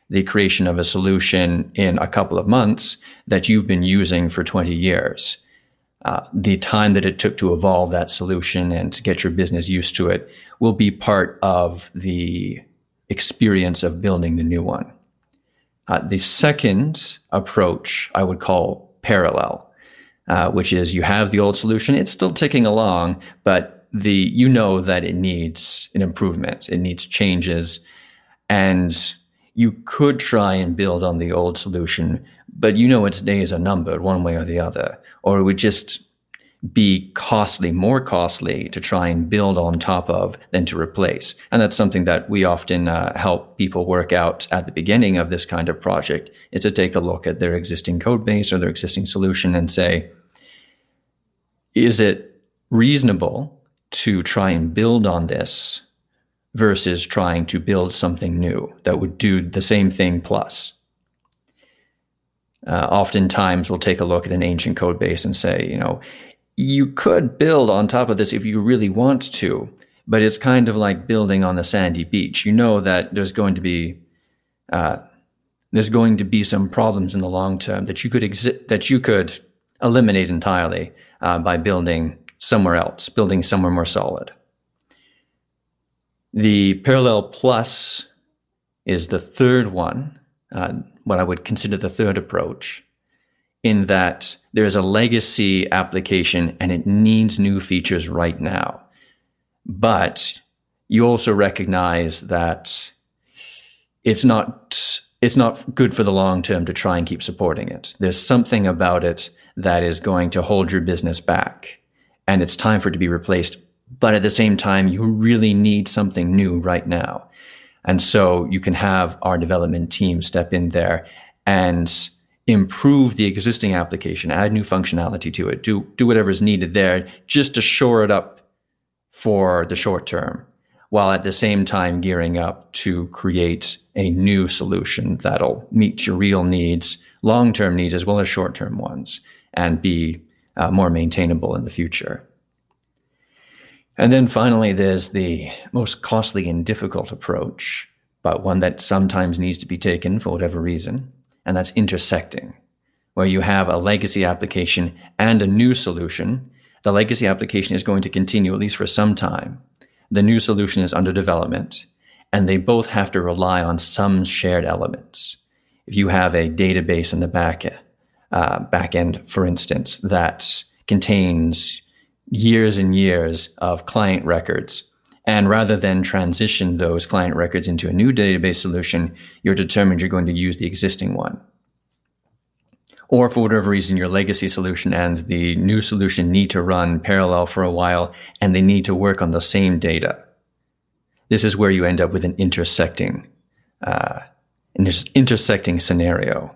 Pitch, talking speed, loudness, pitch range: 95 Hz, 165 wpm, -18 LUFS, 85-105 Hz